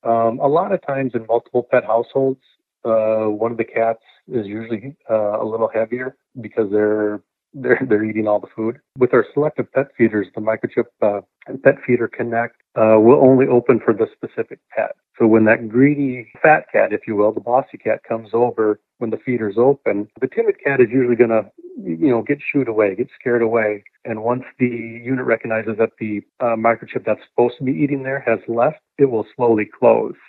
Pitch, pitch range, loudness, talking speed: 115 Hz, 110-130 Hz, -18 LUFS, 200 wpm